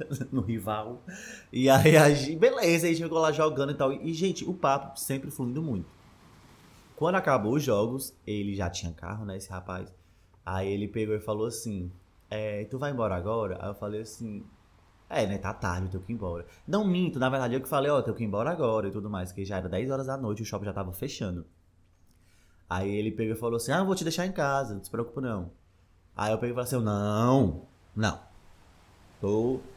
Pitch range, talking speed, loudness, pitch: 95-135 Hz, 225 wpm, -29 LUFS, 110 Hz